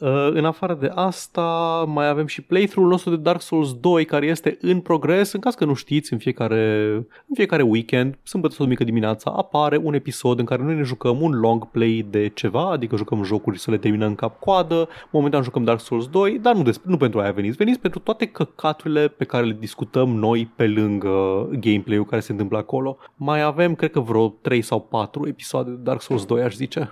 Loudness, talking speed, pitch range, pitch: -21 LUFS, 210 wpm, 115-165 Hz, 135 Hz